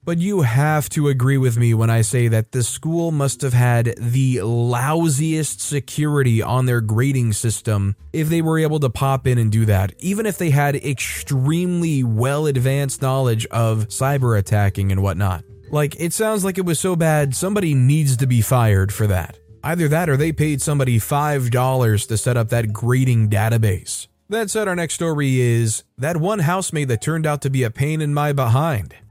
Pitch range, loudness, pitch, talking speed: 115-150 Hz, -19 LUFS, 130 Hz, 190 wpm